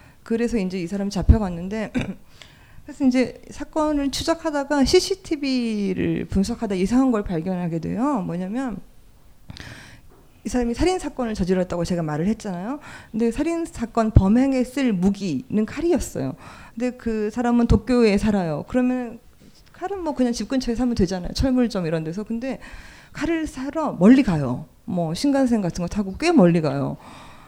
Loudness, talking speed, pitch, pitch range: -22 LUFS, 330 characters per minute, 235 Hz, 195-265 Hz